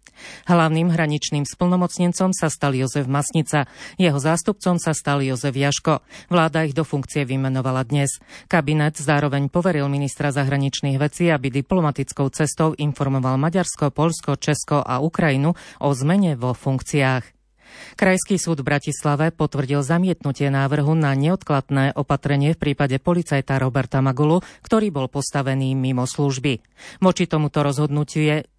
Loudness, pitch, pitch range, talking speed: -21 LUFS, 145 Hz, 140-160 Hz, 130 wpm